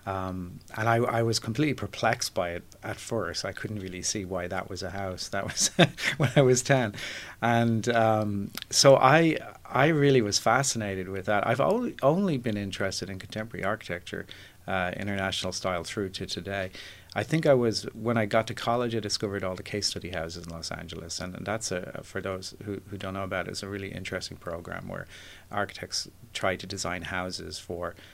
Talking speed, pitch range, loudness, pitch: 200 wpm, 95-115 Hz, -28 LUFS, 100 Hz